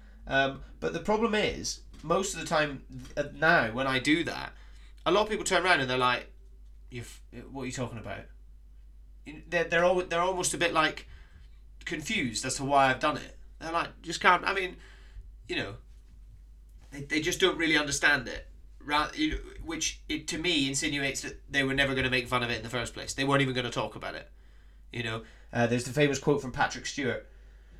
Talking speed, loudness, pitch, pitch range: 220 wpm, -28 LUFS, 135 Hz, 115-155 Hz